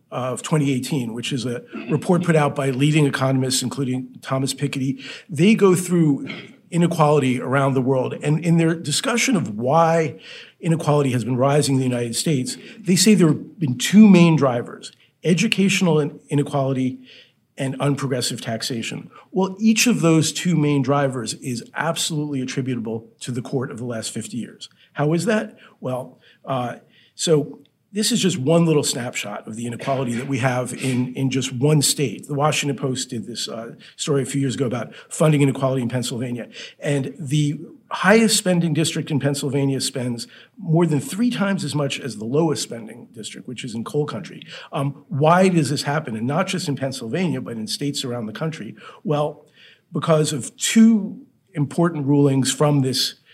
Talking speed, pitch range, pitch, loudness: 170 wpm, 130-165 Hz, 145 Hz, -20 LUFS